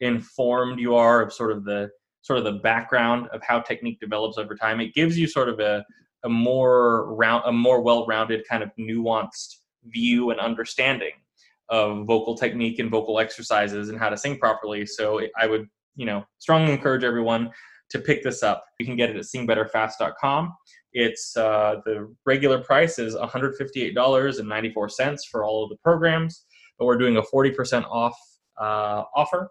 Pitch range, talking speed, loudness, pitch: 110-125 Hz, 175 wpm, -23 LUFS, 115 Hz